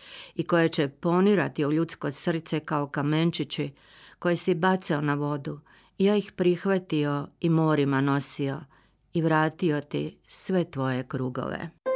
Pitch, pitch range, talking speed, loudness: 155 Hz, 145-175 Hz, 135 wpm, -26 LUFS